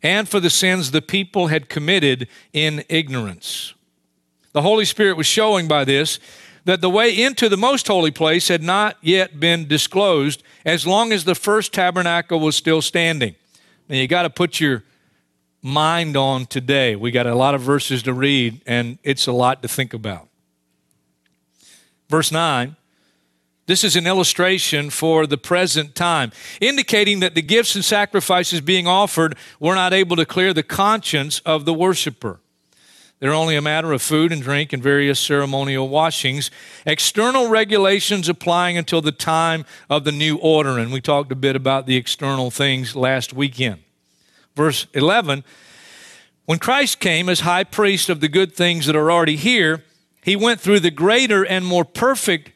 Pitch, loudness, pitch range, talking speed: 160 Hz, -17 LUFS, 135-185 Hz, 170 wpm